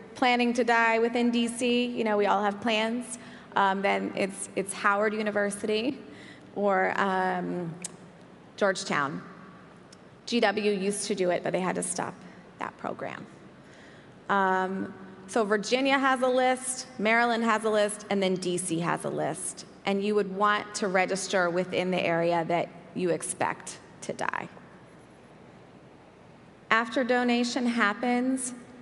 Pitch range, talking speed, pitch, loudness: 190-235 Hz, 135 wpm, 210 Hz, -27 LUFS